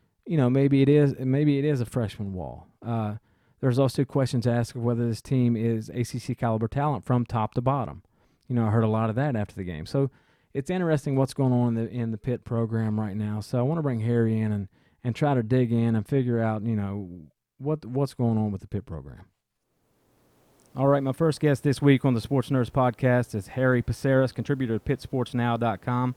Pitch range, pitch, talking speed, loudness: 115-135 Hz, 125 Hz, 220 wpm, -26 LUFS